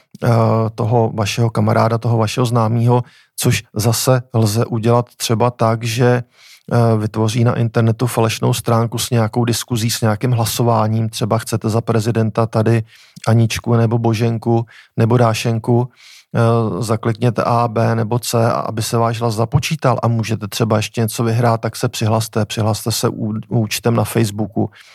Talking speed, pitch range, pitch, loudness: 140 wpm, 115-120 Hz, 115 Hz, -17 LUFS